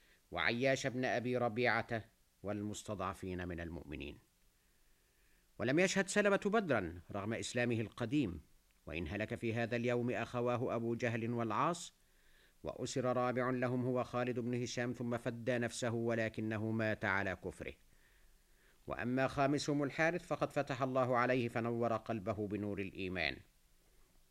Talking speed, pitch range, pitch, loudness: 120 wpm, 105-125 Hz, 120 Hz, -37 LUFS